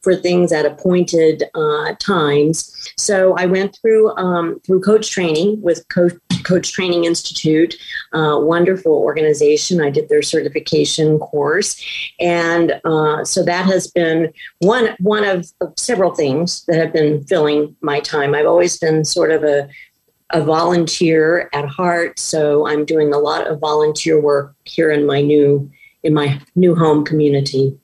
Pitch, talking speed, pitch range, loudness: 165 Hz, 155 wpm, 150-180 Hz, -15 LUFS